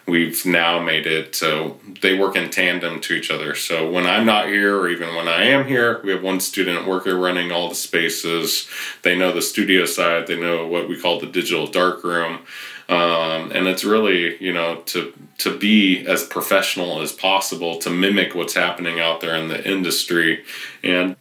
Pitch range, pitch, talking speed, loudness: 85-95 Hz, 90 Hz, 195 wpm, -19 LUFS